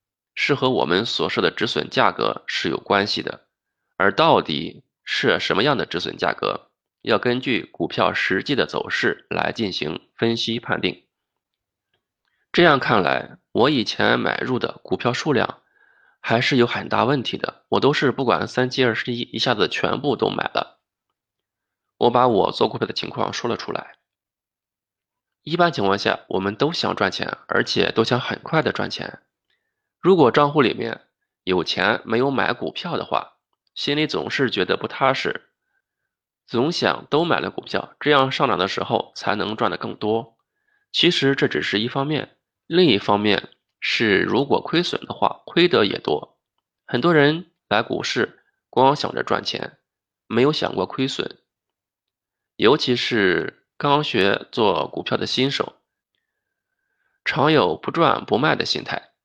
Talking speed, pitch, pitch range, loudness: 225 characters per minute, 135 Hz, 115-175 Hz, -21 LUFS